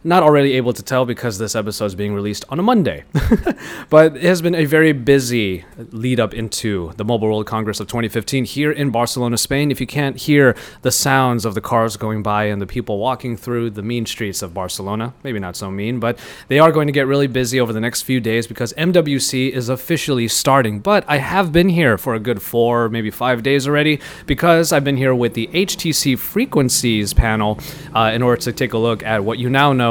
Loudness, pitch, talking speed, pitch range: -17 LUFS, 125 Hz, 225 wpm, 110-140 Hz